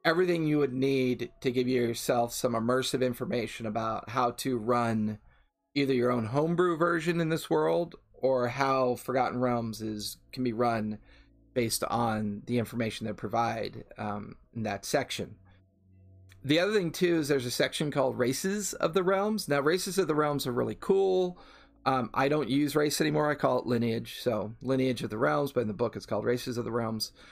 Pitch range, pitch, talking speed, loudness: 115-150 Hz, 125 Hz, 190 wpm, -29 LUFS